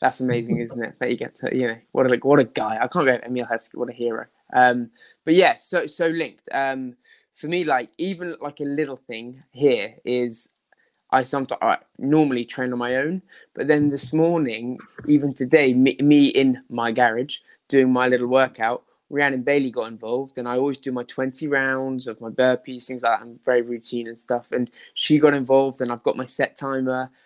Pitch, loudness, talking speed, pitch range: 130 Hz, -22 LUFS, 210 wpm, 120-140 Hz